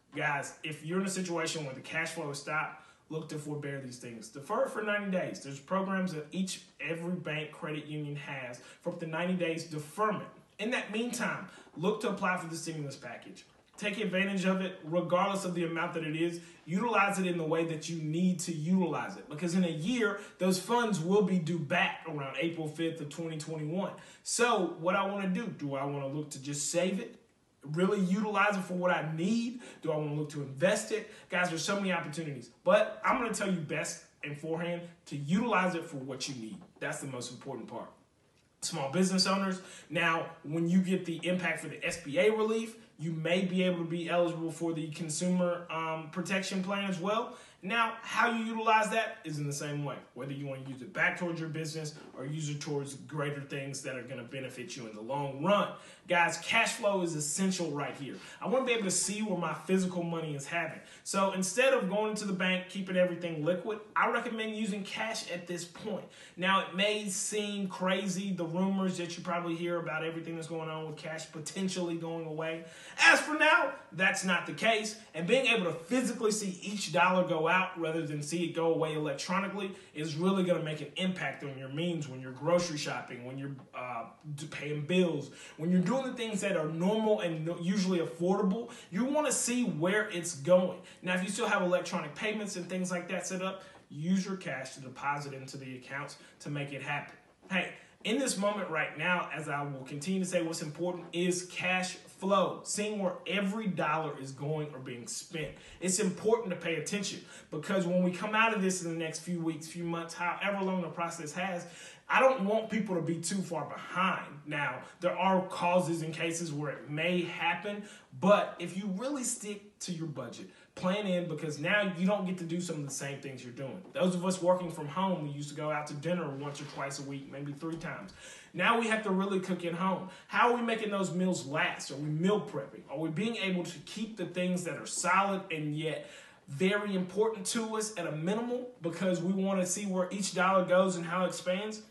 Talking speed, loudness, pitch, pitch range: 215 wpm, -33 LUFS, 175 Hz, 160-195 Hz